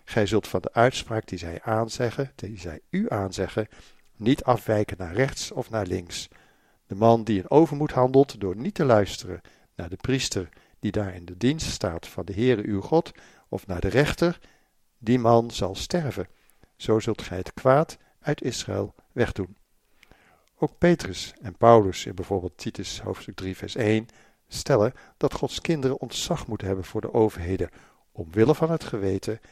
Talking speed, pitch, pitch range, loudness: 170 wpm, 110 Hz, 95-125 Hz, -25 LUFS